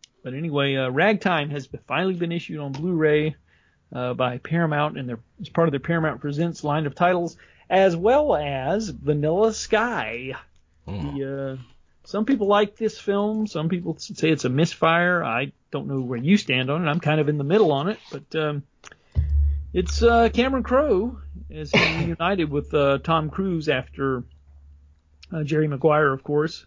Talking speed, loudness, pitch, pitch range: 170 wpm, -23 LUFS, 150 Hz, 130-175 Hz